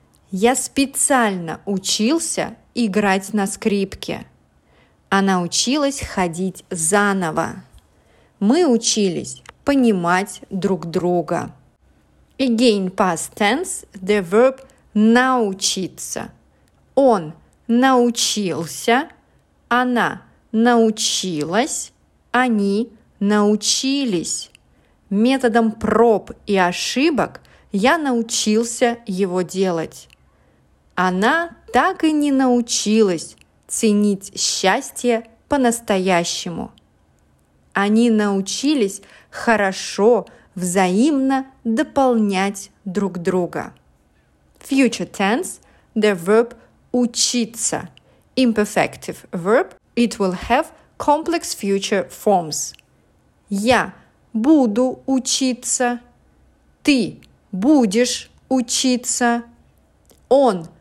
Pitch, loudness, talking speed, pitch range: 220 Hz, -19 LUFS, 70 wpm, 190-245 Hz